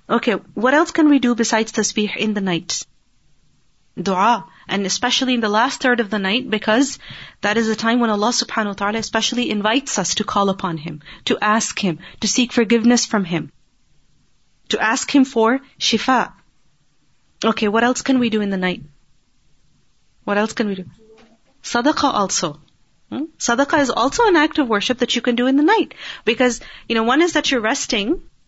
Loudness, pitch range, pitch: -18 LUFS, 210-255 Hz, 230 Hz